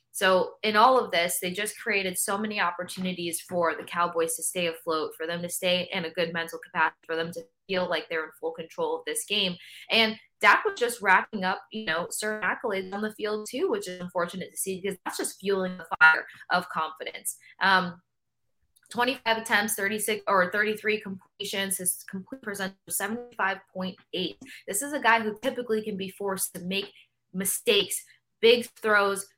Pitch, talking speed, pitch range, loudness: 195 Hz, 190 wpm, 175-215 Hz, -27 LUFS